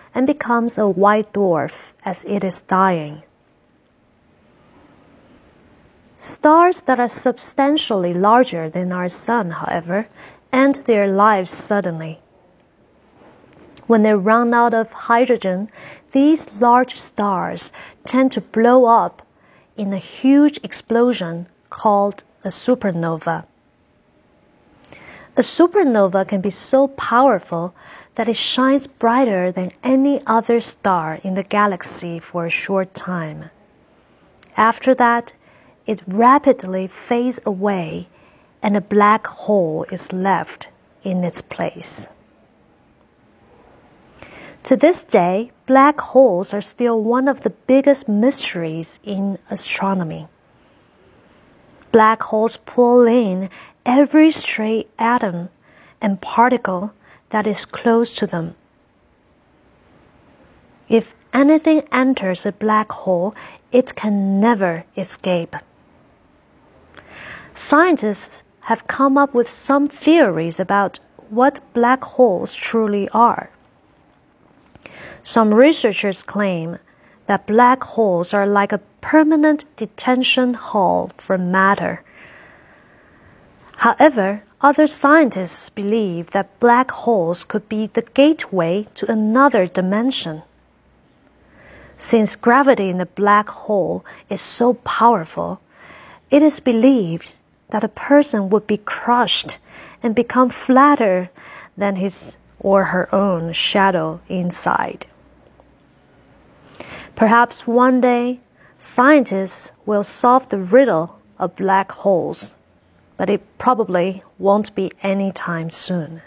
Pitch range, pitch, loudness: 190-245 Hz, 215 Hz, -16 LUFS